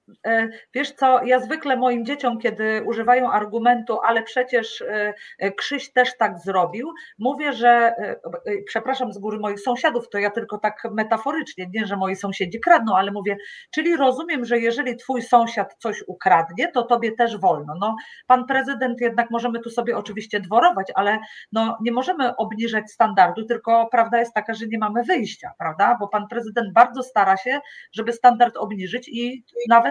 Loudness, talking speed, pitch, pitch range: -21 LUFS, 165 wpm, 235 Hz, 215-250 Hz